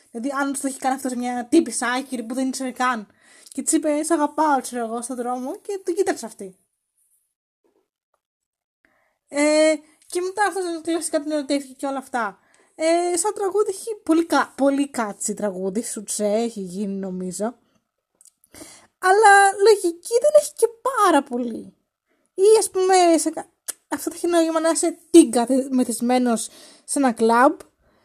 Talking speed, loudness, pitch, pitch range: 150 wpm, -21 LUFS, 290 Hz, 245-340 Hz